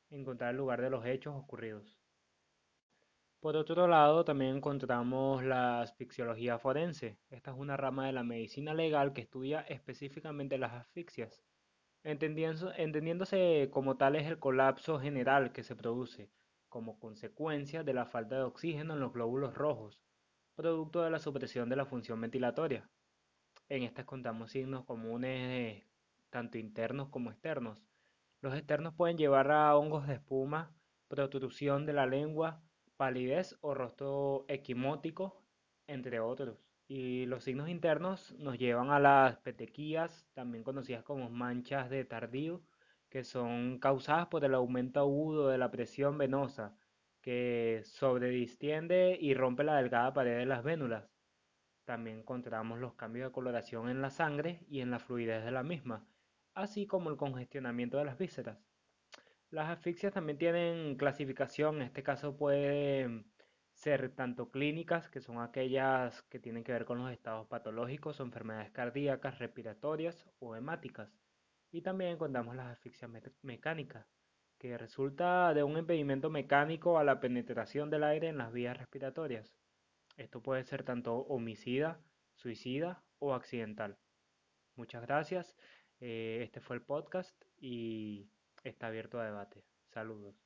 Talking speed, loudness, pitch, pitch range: 140 wpm, -36 LUFS, 135 Hz, 120-150 Hz